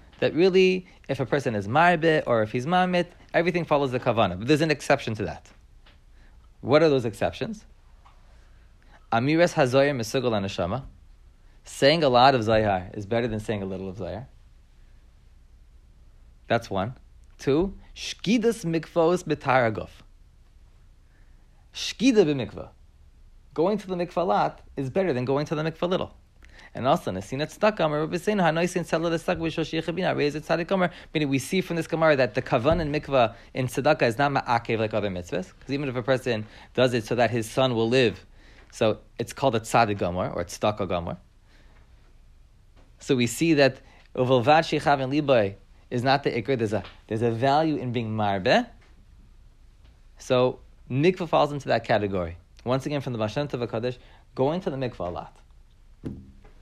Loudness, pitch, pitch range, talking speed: -25 LUFS, 125 Hz, 100-155 Hz, 145 wpm